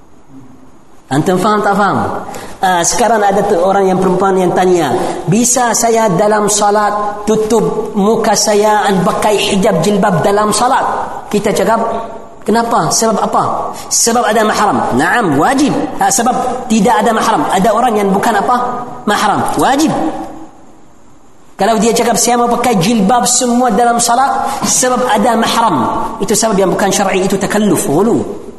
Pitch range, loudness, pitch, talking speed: 205-235 Hz, -11 LUFS, 215 Hz, 135 wpm